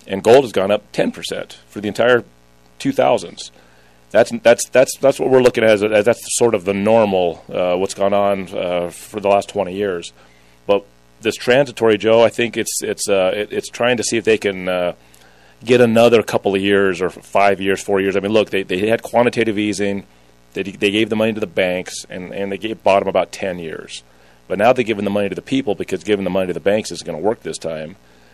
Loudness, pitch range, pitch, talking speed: -17 LUFS, 85-110 Hz, 100 Hz, 235 wpm